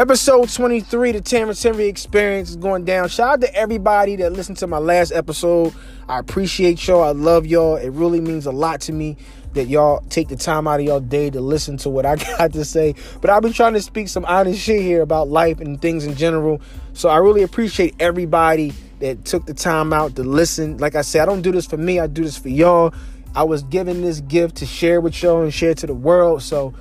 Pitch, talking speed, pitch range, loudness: 165 Hz, 235 wpm, 150-185 Hz, -17 LUFS